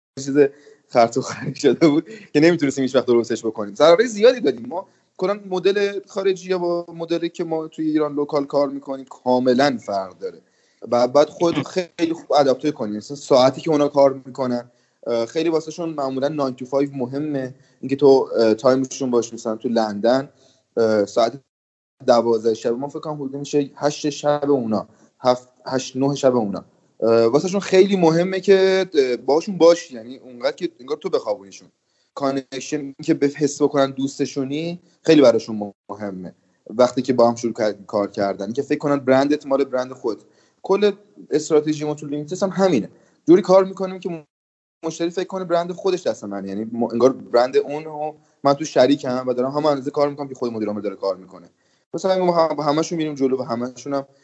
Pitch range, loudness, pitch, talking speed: 125-165 Hz, -20 LUFS, 140 Hz, 175 wpm